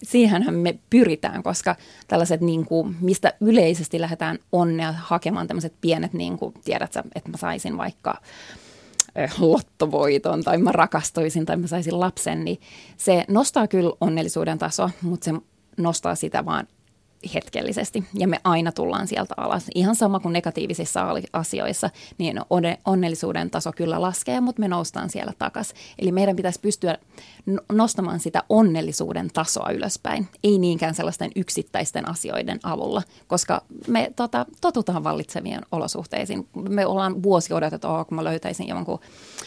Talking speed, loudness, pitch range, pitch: 140 wpm, -23 LUFS, 165-205 Hz, 180 Hz